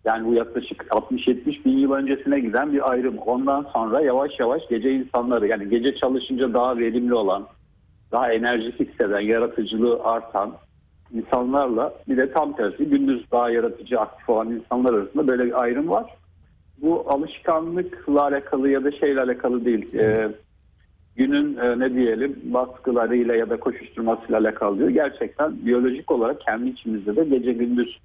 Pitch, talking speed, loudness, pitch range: 125 Hz, 150 wpm, -22 LUFS, 115-140 Hz